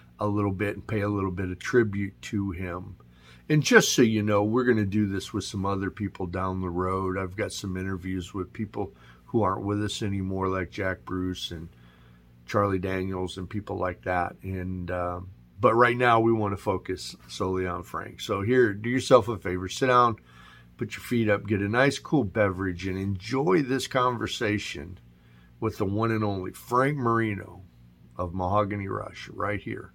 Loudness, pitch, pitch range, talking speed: -27 LUFS, 95 Hz, 90-110 Hz, 190 wpm